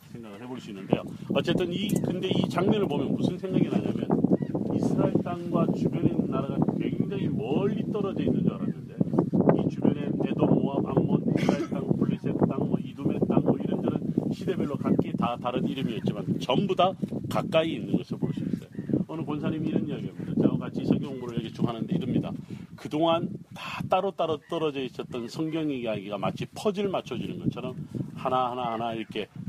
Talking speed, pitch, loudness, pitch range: 380 characters per minute, 160 Hz, -28 LUFS, 125-180 Hz